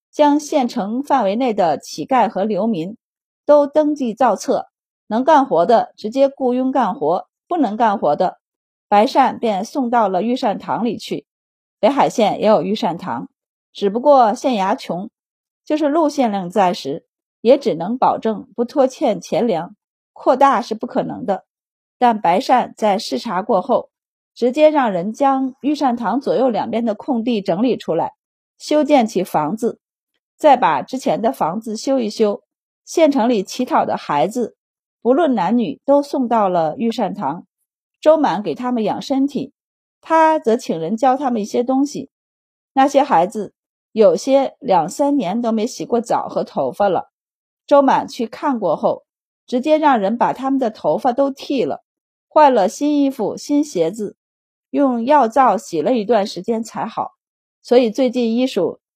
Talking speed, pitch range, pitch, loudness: 225 characters per minute, 220-280 Hz, 250 Hz, -17 LUFS